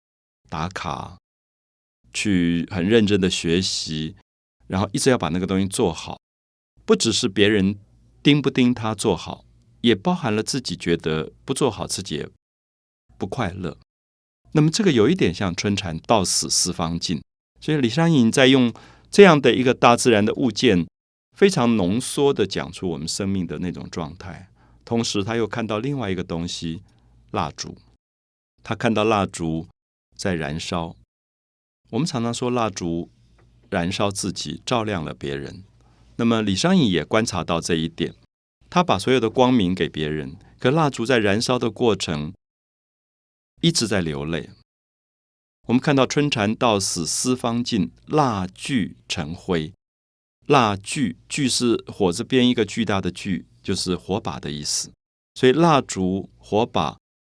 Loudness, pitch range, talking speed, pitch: -21 LUFS, 80-120 Hz, 225 characters per minute, 100 Hz